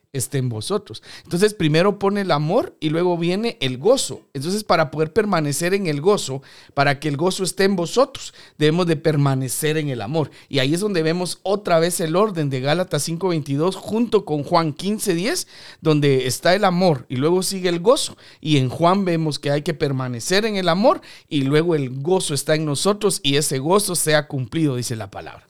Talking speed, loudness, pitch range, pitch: 200 wpm, -20 LUFS, 145-185 Hz, 160 Hz